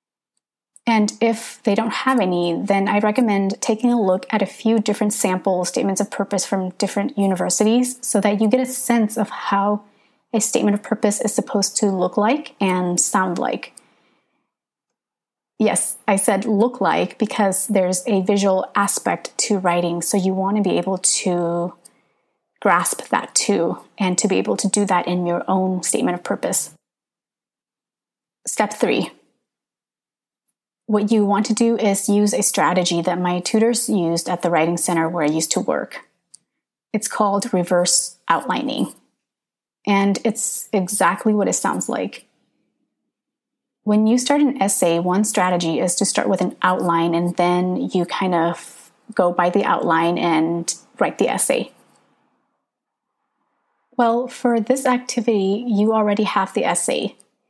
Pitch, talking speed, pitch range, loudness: 200 Hz, 155 wpm, 180-225 Hz, -19 LUFS